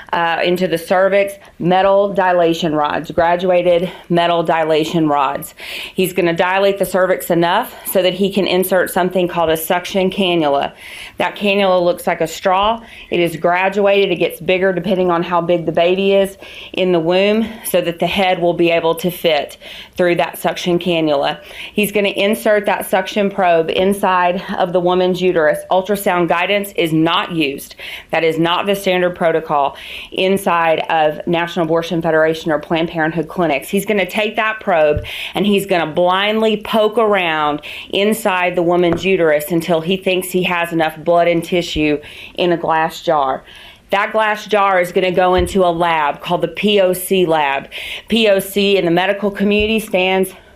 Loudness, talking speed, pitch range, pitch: -15 LUFS, 170 wpm, 170-195 Hz, 180 Hz